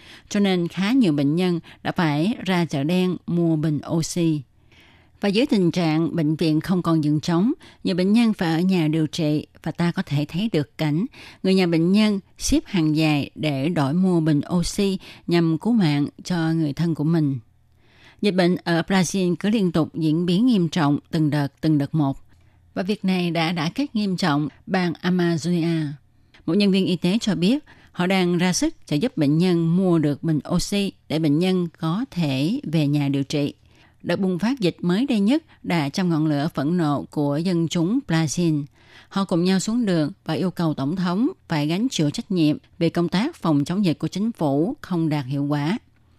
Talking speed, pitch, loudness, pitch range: 205 wpm, 165 Hz, -22 LUFS, 150-185 Hz